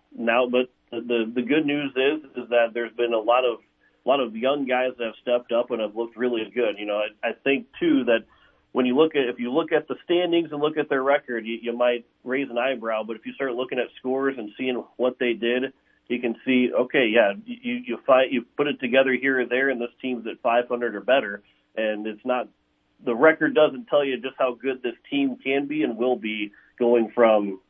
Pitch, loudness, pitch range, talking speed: 125 Hz, -24 LUFS, 115-135 Hz, 240 wpm